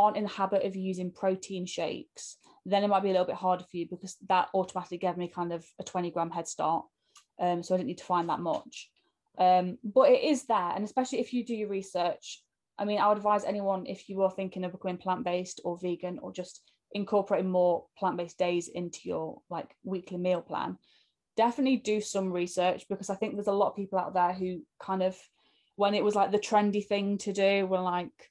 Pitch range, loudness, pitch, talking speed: 180-205 Hz, -30 LUFS, 190 Hz, 225 wpm